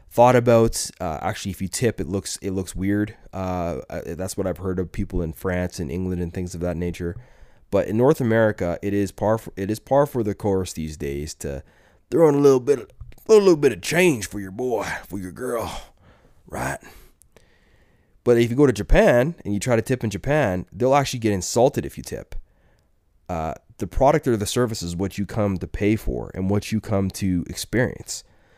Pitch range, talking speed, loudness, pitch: 90-120 Hz, 215 wpm, -22 LUFS, 100 Hz